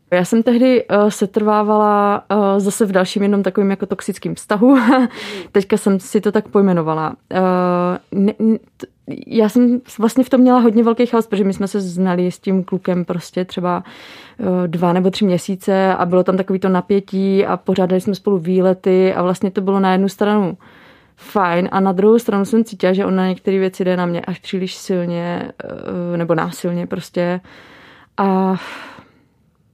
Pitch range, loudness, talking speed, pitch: 185-210 Hz, -16 LUFS, 165 wpm, 195 Hz